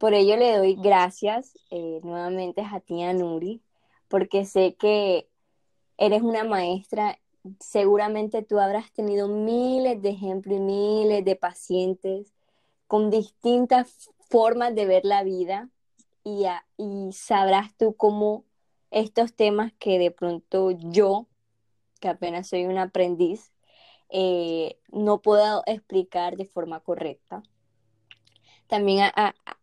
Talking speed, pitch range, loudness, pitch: 125 wpm, 180-215 Hz, -24 LUFS, 200 Hz